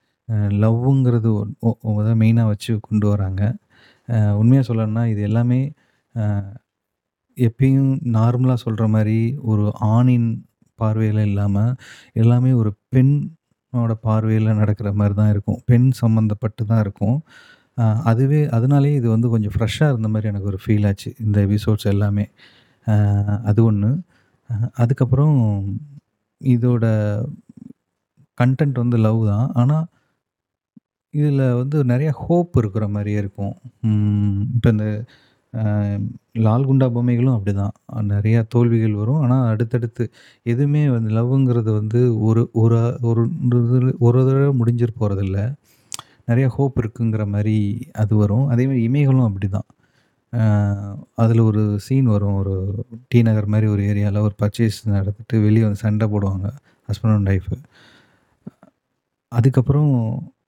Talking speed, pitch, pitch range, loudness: 110 wpm, 115 Hz, 105-125 Hz, -19 LUFS